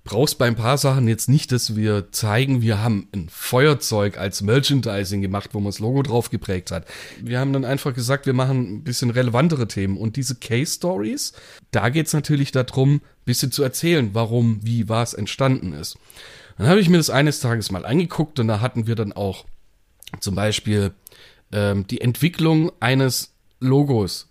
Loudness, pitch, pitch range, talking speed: -21 LUFS, 120 Hz, 105-135 Hz, 185 wpm